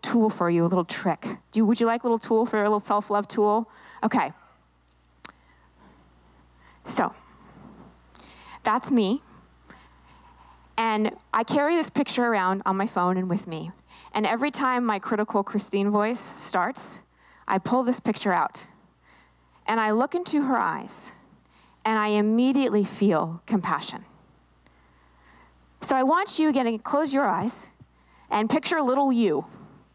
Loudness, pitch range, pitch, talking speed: -25 LUFS, 170-245 Hz, 210 Hz, 140 wpm